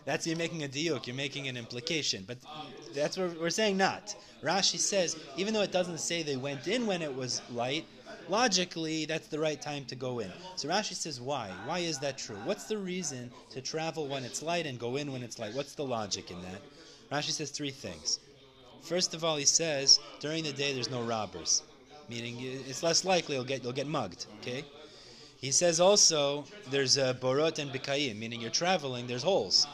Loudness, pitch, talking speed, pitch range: -31 LUFS, 145 Hz, 205 wpm, 130-165 Hz